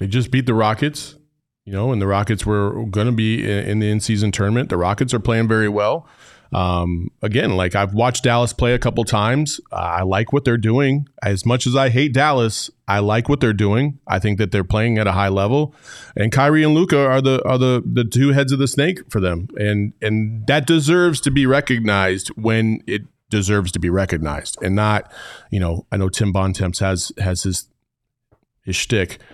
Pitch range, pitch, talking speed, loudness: 100-130 Hz, 110 Hz, 205 wpm, -18 LUFS